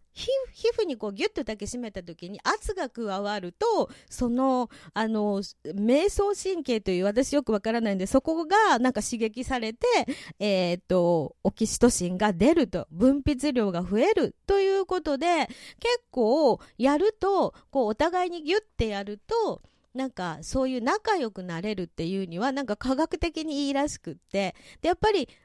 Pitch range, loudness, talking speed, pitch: 205-335 Hz, -27 LUFS, 325 characters per minute, 255 Hz